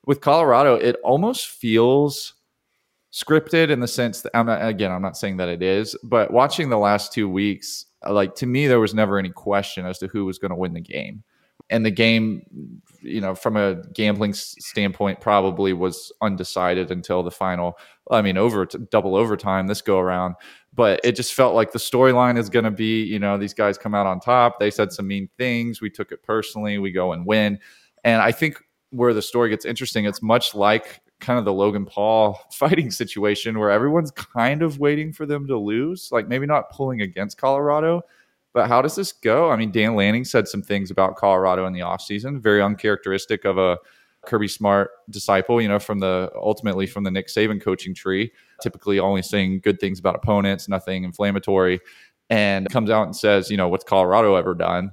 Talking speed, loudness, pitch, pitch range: 200 wpm, -21 LUFS, 105 Hz, 95-115 Hz